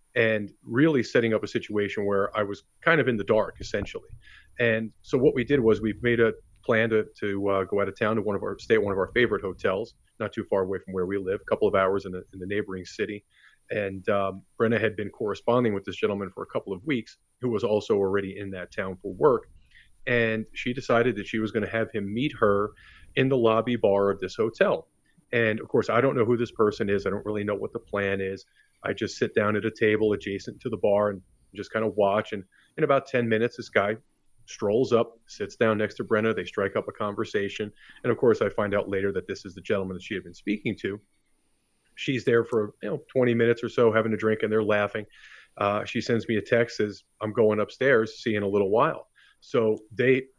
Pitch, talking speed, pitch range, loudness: 105 Hz, 250 wpm, 100-115 Hz, -26 LUFS